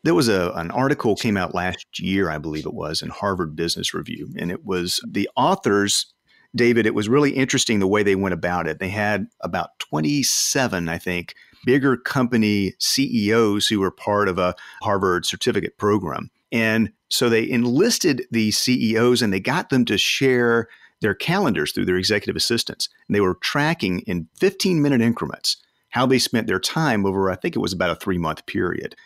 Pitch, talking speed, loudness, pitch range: 110 Hz, 190 wpm, -21 LUFS, 95-125 Hz